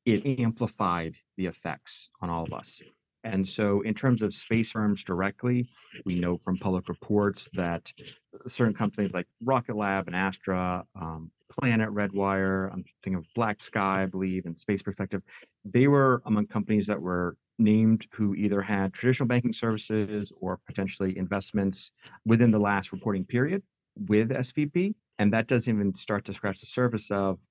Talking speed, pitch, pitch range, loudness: 165 wpm, 105 Hz, 95-115 Hz, -28 LUFS